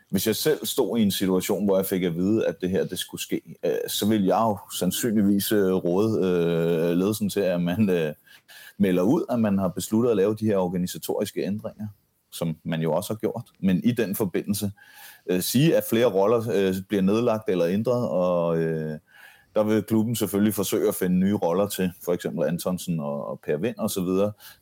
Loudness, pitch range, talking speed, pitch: -24 LUFS, 90-105 Hz, 205 wpm, 95 Hz